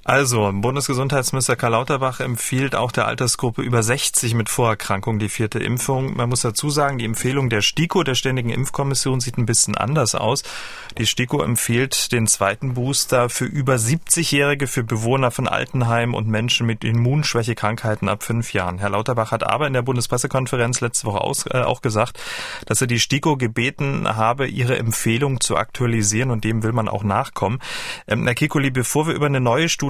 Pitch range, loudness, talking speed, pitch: 115-135 Hz, -20 LUFS, 170 wpm, 125 Hz